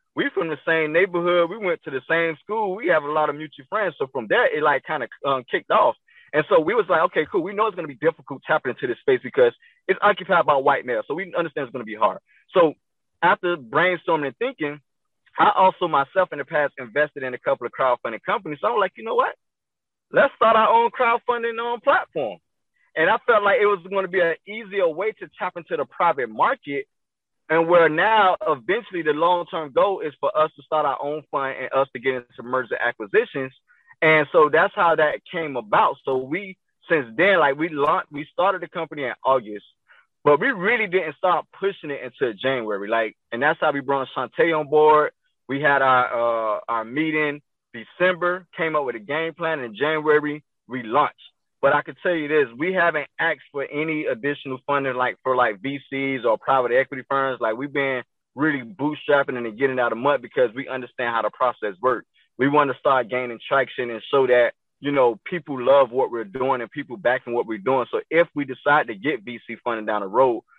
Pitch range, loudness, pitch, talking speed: 130-180 Hz, -22 LUFS, 150 Hz, 215 wpm